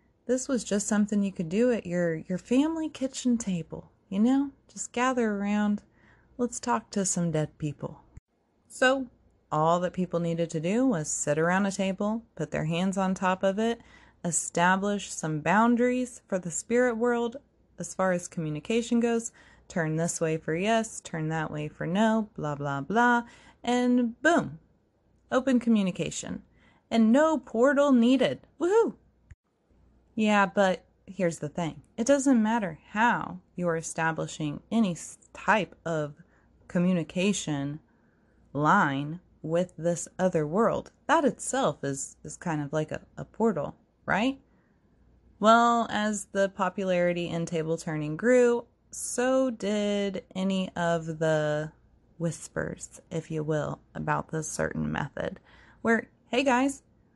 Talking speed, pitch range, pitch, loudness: 140 wpm, 165-235 Hz, 195 Hz, -28 LUFS